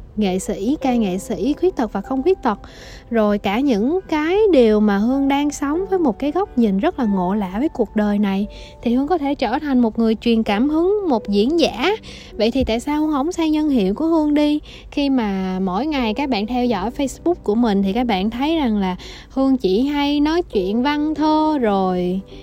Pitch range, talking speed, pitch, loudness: 210-295 Hz, 225 wpm, 255 Hz, -19 LUFS